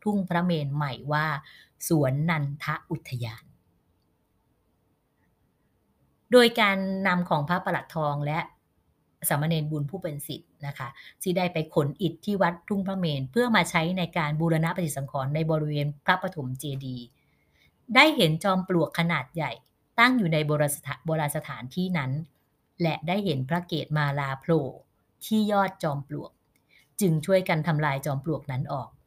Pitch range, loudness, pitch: 140-175 Hz, -26 LUFS, 155 Hz